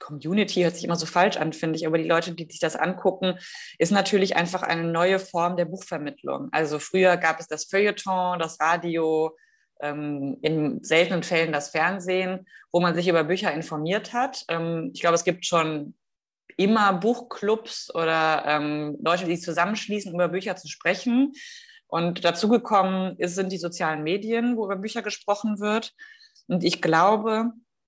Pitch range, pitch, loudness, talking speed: 165-205 Hz, 175 Hz, -24 LUFS, 160 wpm